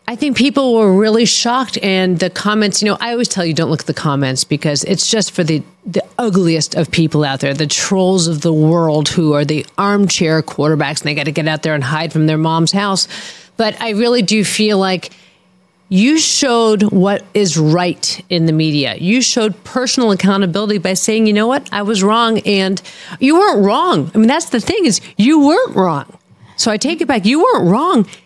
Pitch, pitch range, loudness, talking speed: 195 Hz, 160-225 Hz, -13 LUFS, 215 wpm